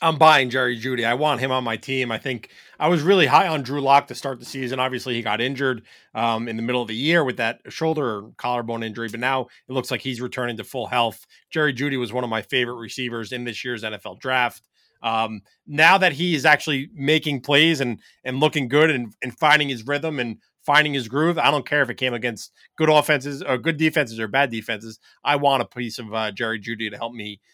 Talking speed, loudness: 240 wpm, -21 LUFS